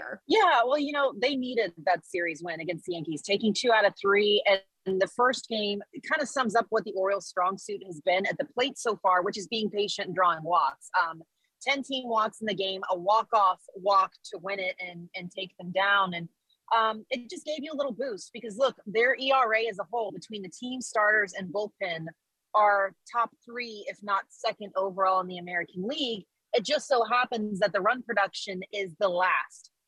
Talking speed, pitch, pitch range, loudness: 215 wpm, 205 Hz, 190-240 Hz, -28 LUFS